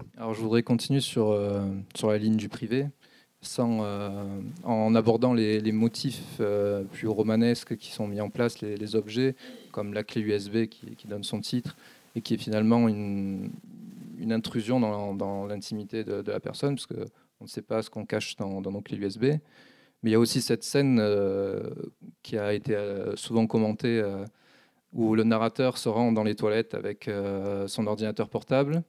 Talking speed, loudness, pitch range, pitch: 195 wpm, -28 LUFS, 105-125 Hz, 110 Hz